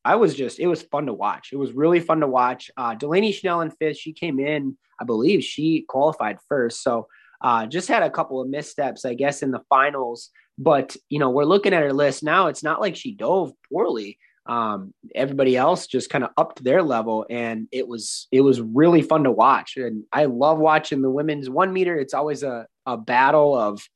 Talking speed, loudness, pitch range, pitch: 220 wpm, -21 LUFS, 130-160 Hz, 145 Hz